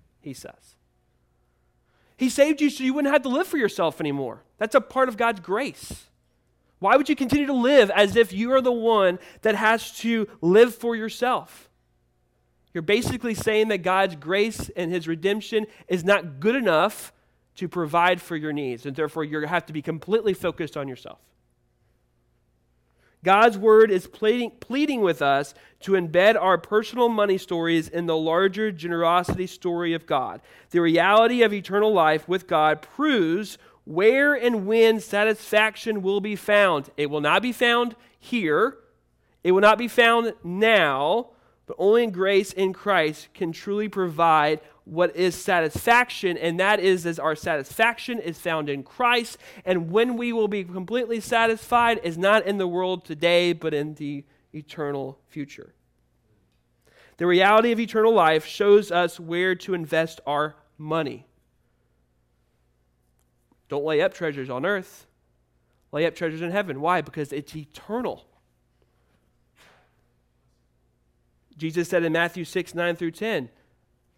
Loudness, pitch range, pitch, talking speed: -22 LUFS, 150-220 Hz, 180 Hz, 150 wpm